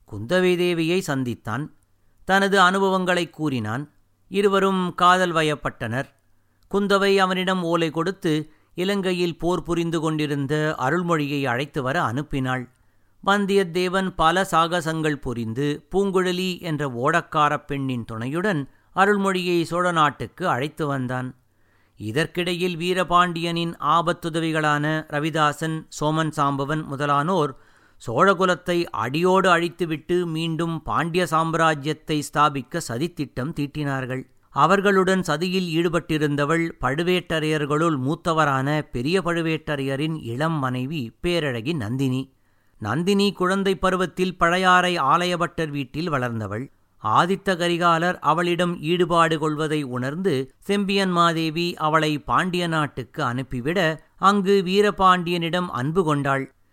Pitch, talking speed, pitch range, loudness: 160 Hz, 90 wpm, 140-180 Hz, -22 LUFS